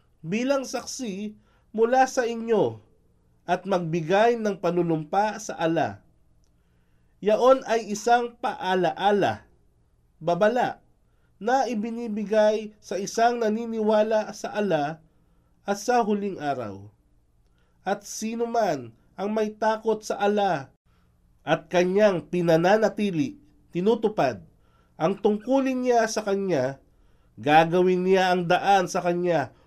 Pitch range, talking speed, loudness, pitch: 155-220 Hz, 100 wpm, -24 LUFS, 195 Hz